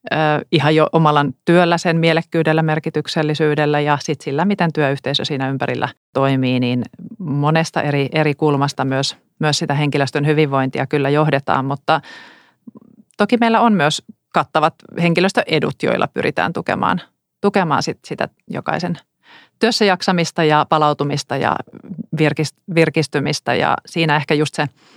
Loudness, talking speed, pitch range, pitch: -17 LUFS, 125 wpm, 145-170 Hz, 155 Hz